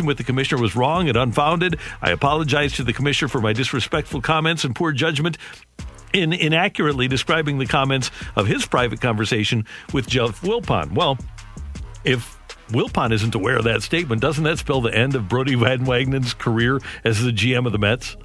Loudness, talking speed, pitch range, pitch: -20 LUFS, 180 wpm, 115-150 Hz, 130 Hz